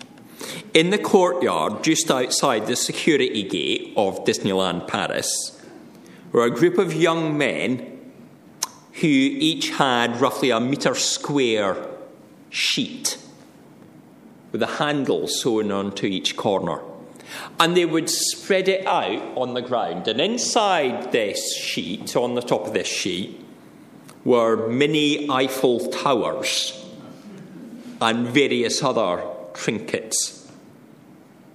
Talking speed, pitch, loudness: 110 wpm, 165 Hz, -21 LUFS